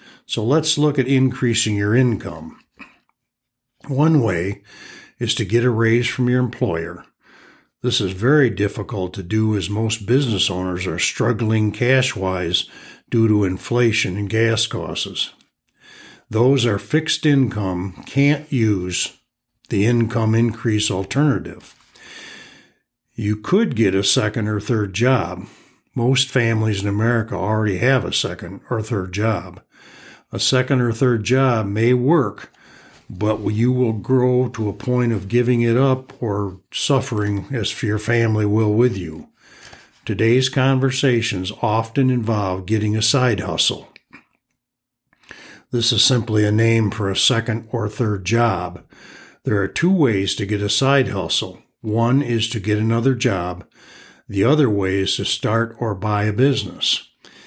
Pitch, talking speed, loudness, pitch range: 115 Hz, 140 wpm, -19 LUFS, 100-125 Hz